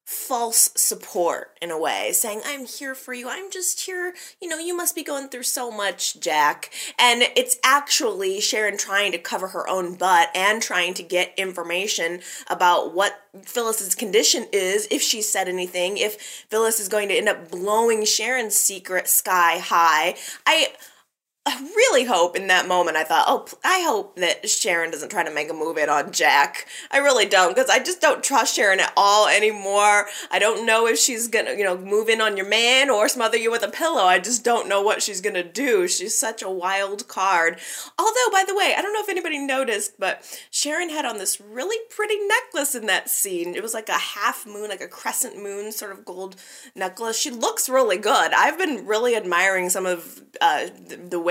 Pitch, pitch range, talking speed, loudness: 225 Hz, 195-290 Hz, 205 wpm, -20 LUFS